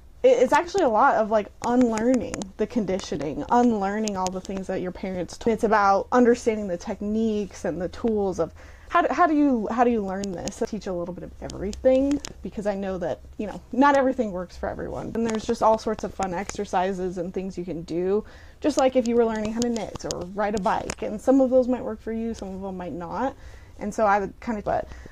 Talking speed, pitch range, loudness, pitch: 240 wpm, 190-240 Hz, -24 LUFS, 215 Hz